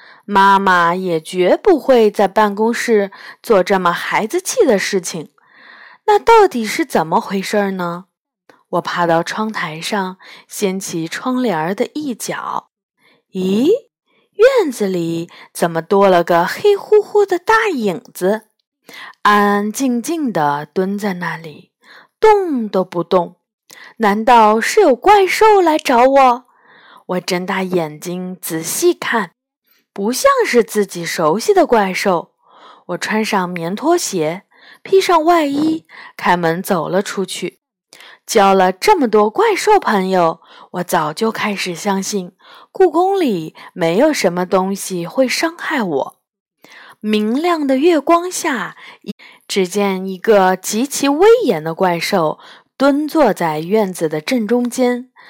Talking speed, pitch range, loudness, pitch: 180 characters per minute, 185-285 Hz, -15 LUFS, 210 Hz